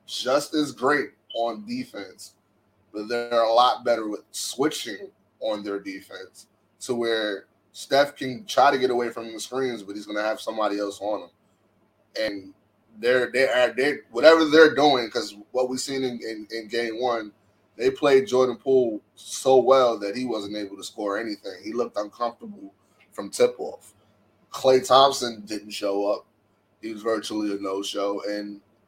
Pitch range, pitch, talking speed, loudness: 105-130 Hz, 115 Hz, 170 wpm, -24 LUFS